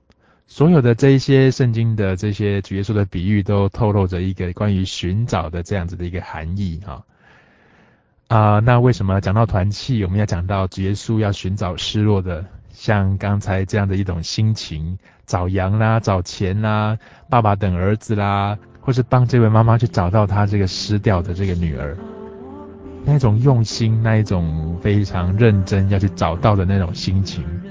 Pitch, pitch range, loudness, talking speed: 100 Hz, 95-110 Hz, -18 LUFS, 270 characters per minute